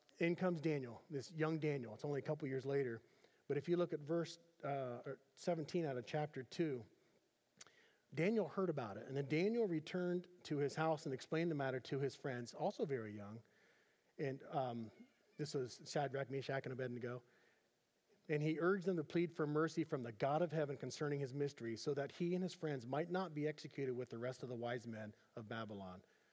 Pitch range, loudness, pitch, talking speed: 130-165 Hz, -43 LUFS, 145 Hz, 200 wpm